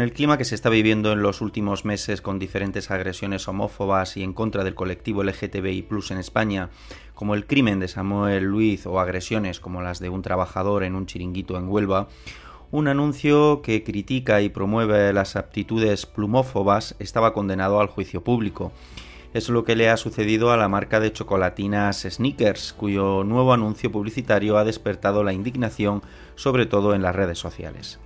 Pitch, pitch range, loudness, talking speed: 100 Hz, 95-110 Hz, -23 LUFS, 175 wpm